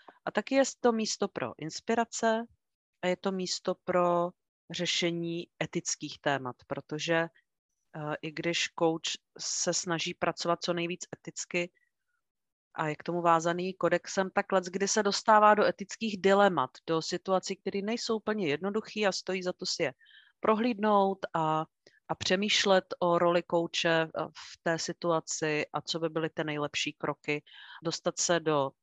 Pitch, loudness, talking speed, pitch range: 175 Hz, -30 LUFS, 150 wpm, 165-195 Hz